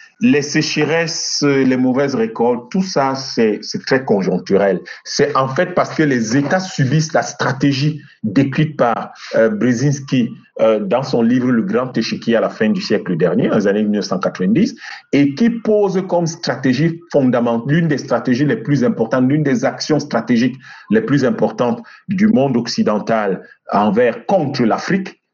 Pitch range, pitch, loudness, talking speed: 125-165 Hz, 140 Hz, -16 LUFS, 155 wpm